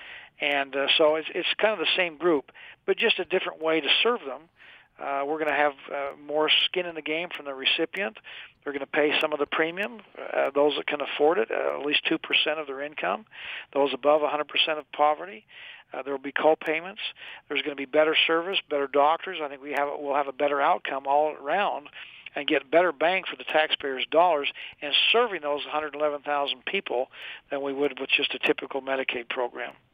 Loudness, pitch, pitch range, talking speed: -25 LUFS, 150 Hz, 145-175 Hz, 210 wpm